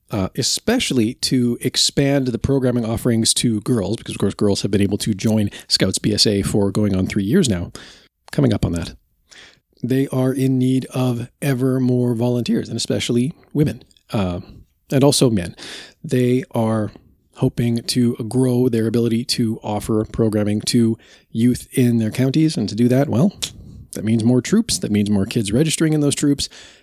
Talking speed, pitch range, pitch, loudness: 170 wpm, 110-130 Hz, 120 Hz, -19 LUFS